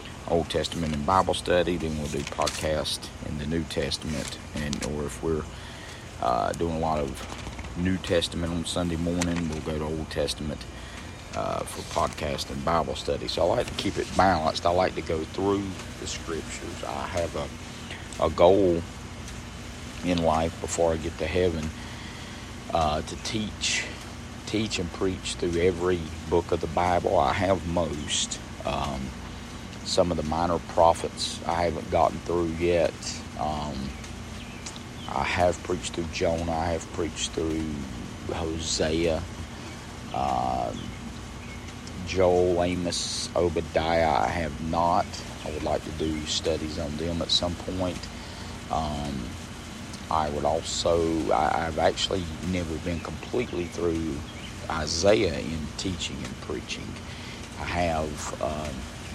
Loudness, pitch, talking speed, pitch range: -28 LUFS, 85 Hz, 140 wpm, 80-90 Hz